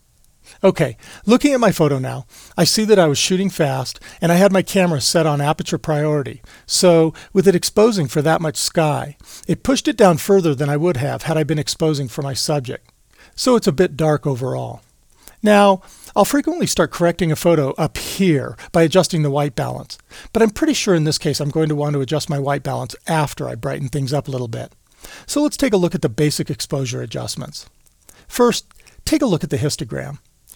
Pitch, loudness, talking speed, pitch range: 160 Hz, -18 LUFS, 210 wpm, 145-190 Hz